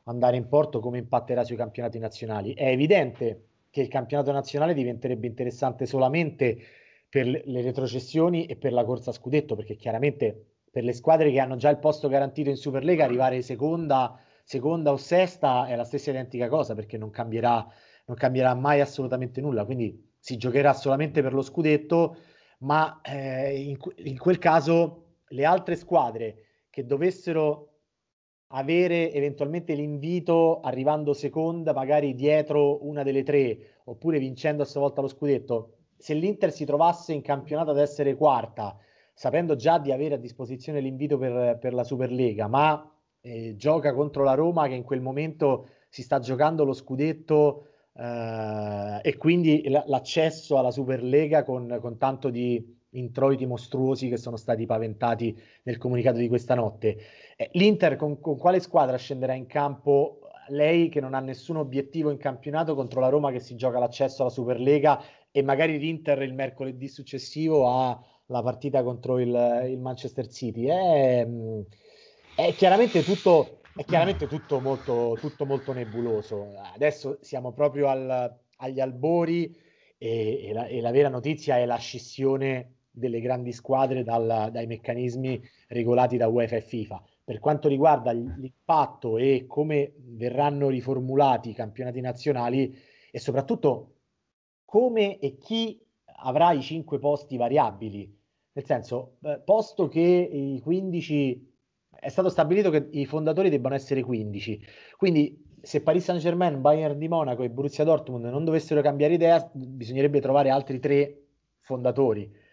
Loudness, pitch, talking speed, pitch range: -26 LUFS, 135 Hz, 150 wpm, 125-150 Hz